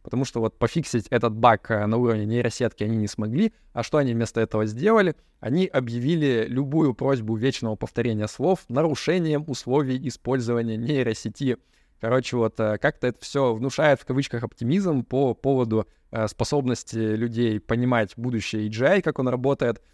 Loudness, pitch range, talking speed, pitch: -24 LUFS, 115-135 Hz, 145 wpm, 120 Hz